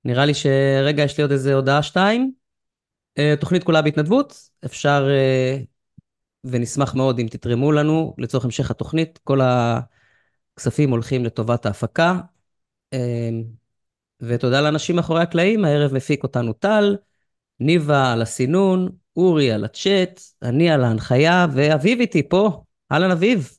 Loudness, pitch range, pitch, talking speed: -19 LUFS, 125-170 Hz, 145 Hz, 120 wpm